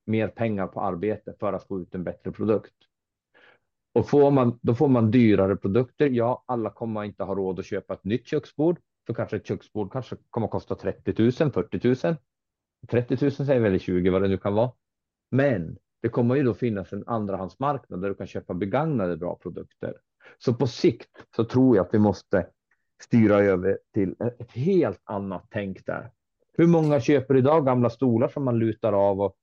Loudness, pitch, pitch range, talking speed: -25 LUFS, 115 Hz, 100-125 Hz, 195 wpm